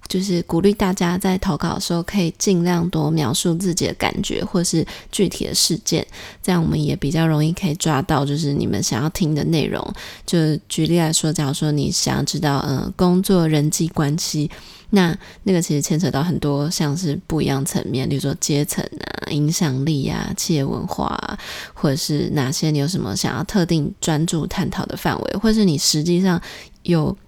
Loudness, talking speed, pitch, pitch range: -20 LUFS, 295 characters per minute, 160 Hz, 150-180 Hz